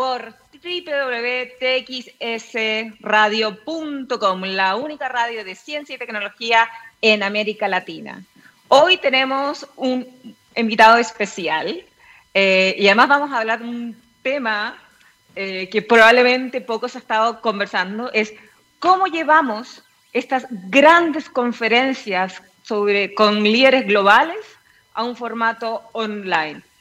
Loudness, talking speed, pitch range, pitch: -18 LUFS, 105 wpm, 215-260 Hz, 235 Hz